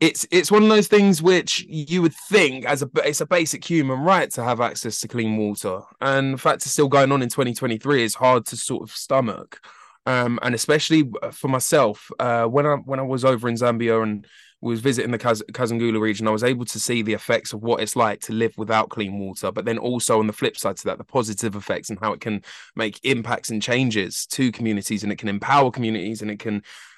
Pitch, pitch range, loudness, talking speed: 120 Hz, 110-140 Hz, -21 LUFS, 235 wpm